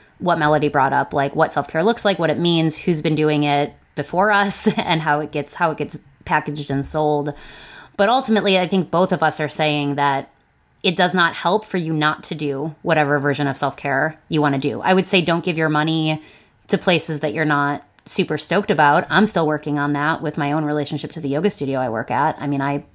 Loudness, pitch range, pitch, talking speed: -19 LUFS, 145-175 Hz, 155 Hz, 240 wpm